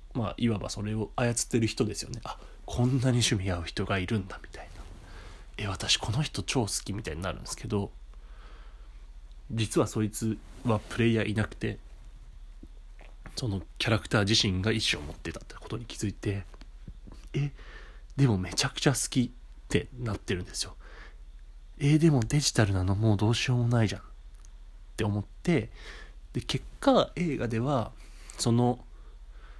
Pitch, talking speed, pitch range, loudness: 110 Hz, 310 characters per minute, 100-120 Hz, -29 LUFS